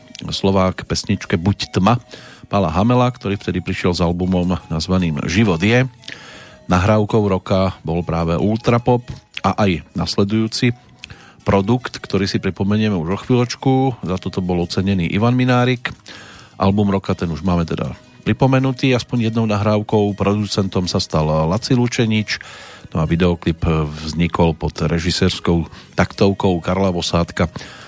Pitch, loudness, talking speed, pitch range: 100 Hz, -18 LUFS, 125 wpm, 90-110 Hz